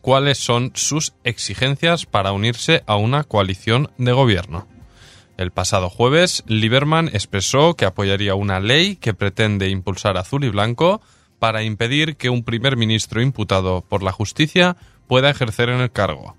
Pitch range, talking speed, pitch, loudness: 100-135 Hz, 150 wpm, 115 Hz, -18 LUFS